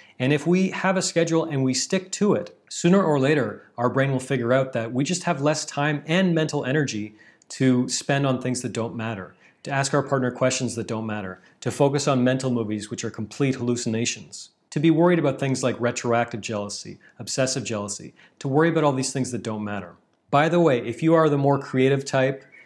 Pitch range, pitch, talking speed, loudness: 120-150 Hz, 130 Hz, 215 wpm, -23 LUFS